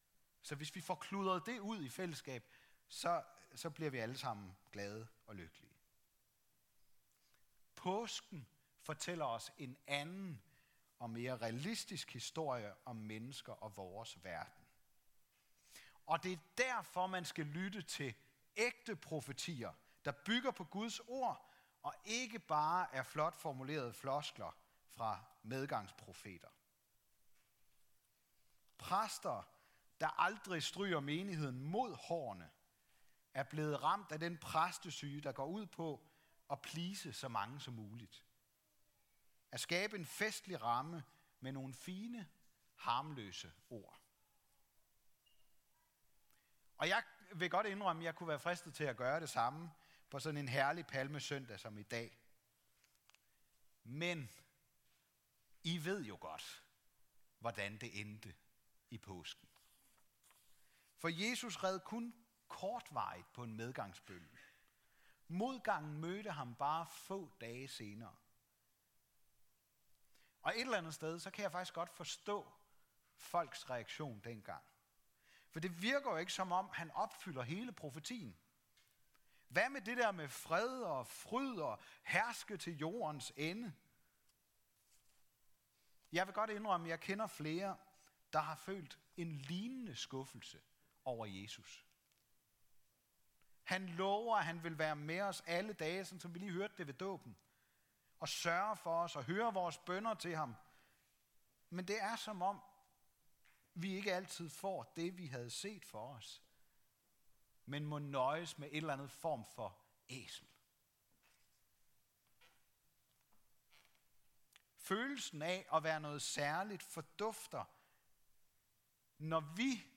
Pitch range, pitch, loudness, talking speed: 125-185 Hz, 155 Hz, -43 LUFS, 125 wpm